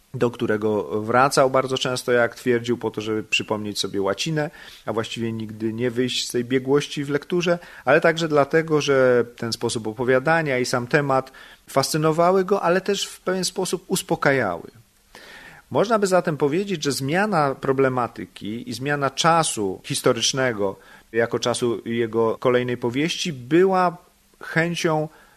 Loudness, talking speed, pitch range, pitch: -22 LUFS, 140 wpm, 120-165 Hz, 130 Hz